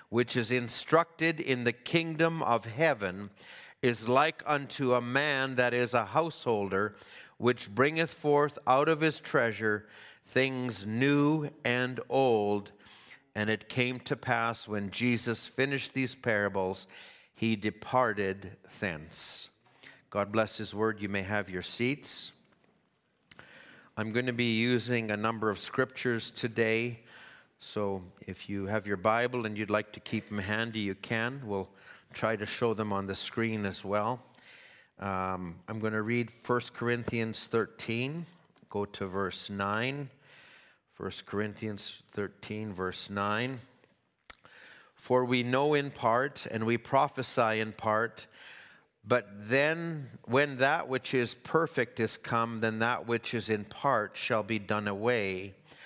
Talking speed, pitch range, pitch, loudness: 140 wpm, 105-125 Hz, 115 Hz, -31 LUFS